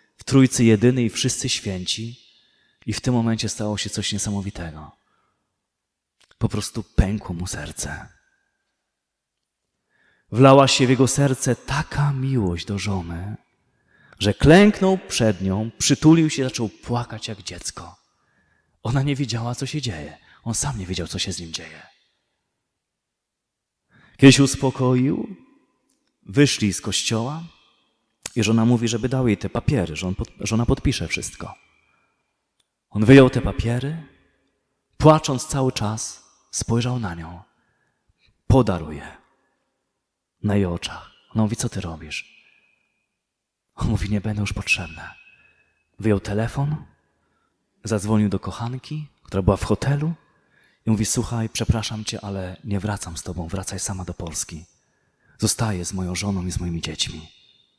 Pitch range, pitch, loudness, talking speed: 95-125 Hz, 110 Hz, -21 LUFS, 135 wpm